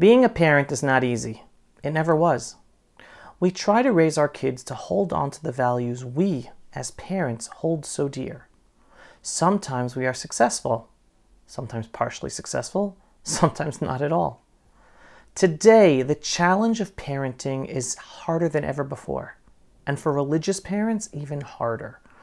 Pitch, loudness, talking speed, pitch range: 145 Hz, -23 LUFS, 145 wpm, 130-180 Hz